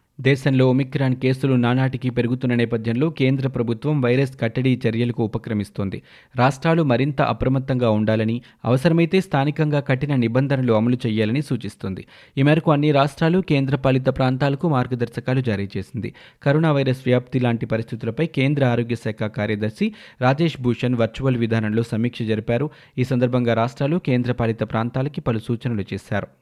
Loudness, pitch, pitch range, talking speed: -21 LUFS, 125 Hz, 115-140 Hz, 125 wpm